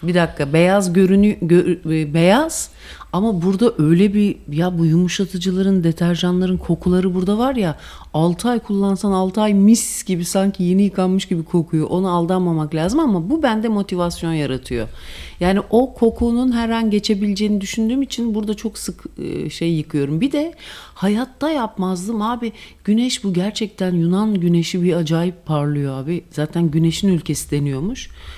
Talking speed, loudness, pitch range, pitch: 145 wpm, -18 LUFS, 170-215 Hz, 185 Hz